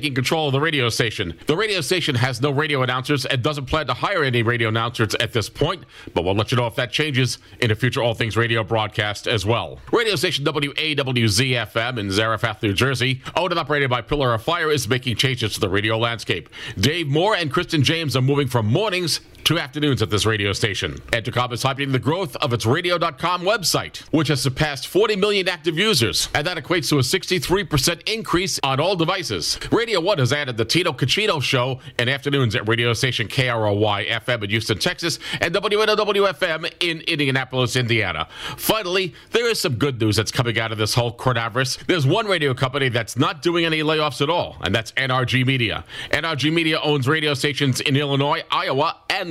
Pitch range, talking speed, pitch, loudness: 115-155 Hz, 195 wpm, 135 Hz, -20 LUFS